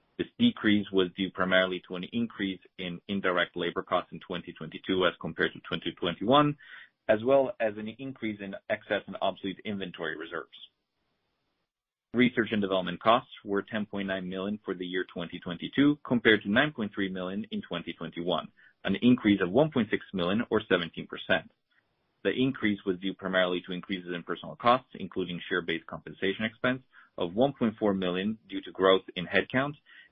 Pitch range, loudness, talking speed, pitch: 90-115 Hz, -29 LUFS, 150 wpm, 100 Hz